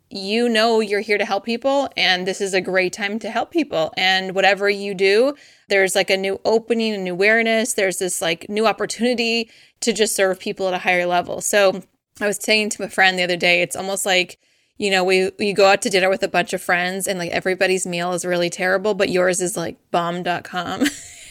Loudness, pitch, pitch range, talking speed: -19 LUFS, 195 Hz, 185-210 Hz, 225 wpm